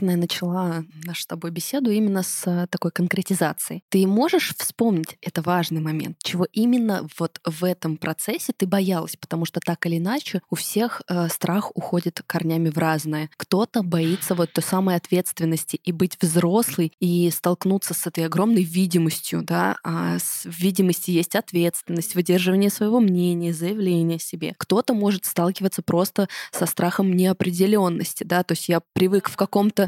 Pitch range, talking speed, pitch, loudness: 170-195 Hz, 155 wpm, 180 Hz, -22 LUFS